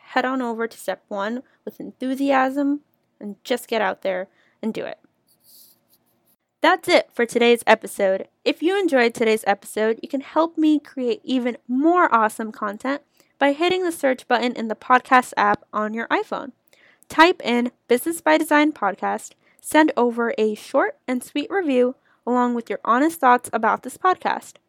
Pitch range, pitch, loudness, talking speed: 225-295 Hz, 250 Hz, -21 LUFS, 165 wpm